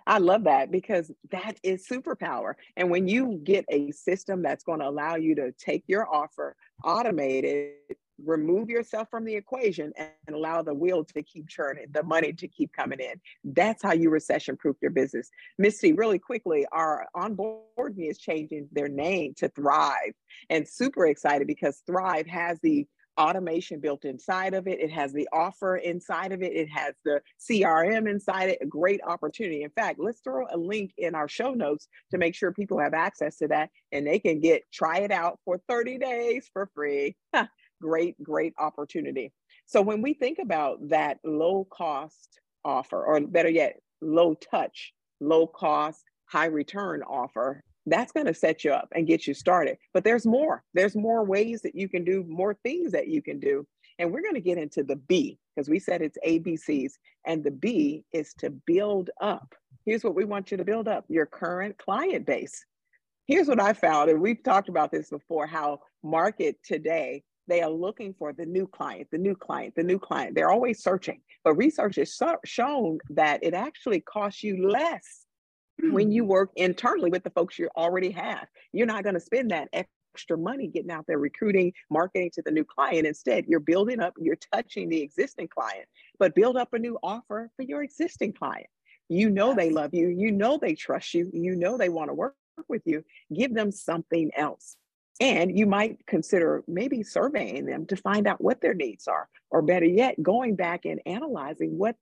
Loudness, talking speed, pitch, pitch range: -27 LUFS, 190 wpm, 180 Hz, 160-215 Hz